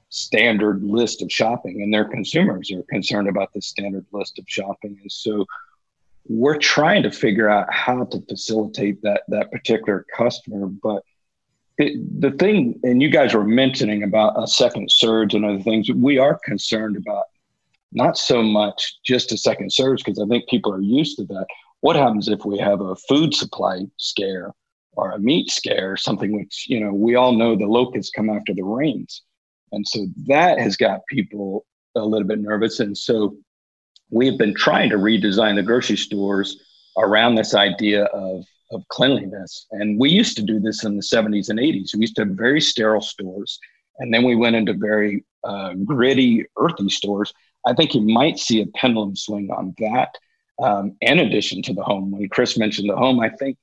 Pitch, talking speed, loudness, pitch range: 105 Hz, 185 wpm, -19 LUFS, 100-115 Hz